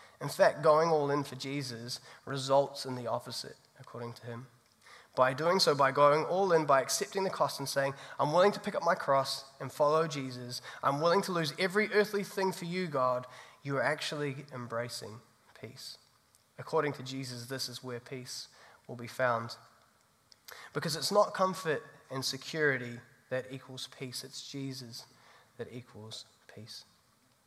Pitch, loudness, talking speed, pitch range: 135 Hz, -32 LUFS, 165 wpm, 125-155 Hz